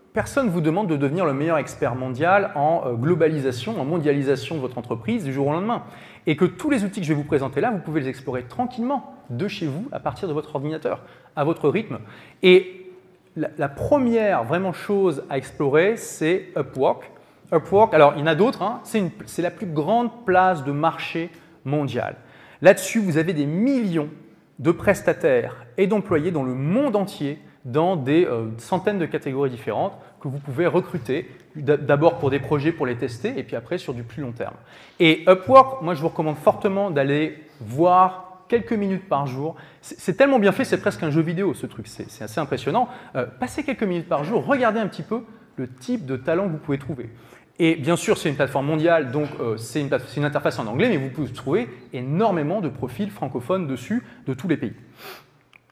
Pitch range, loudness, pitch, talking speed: 140-195 Hz, -22 LUFS, 165 Hz, 195 wpm